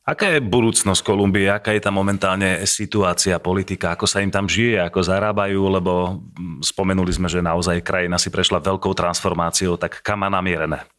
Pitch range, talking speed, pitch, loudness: 90-100 Hz, 170 wpm, 95 Hz, -19 LUFS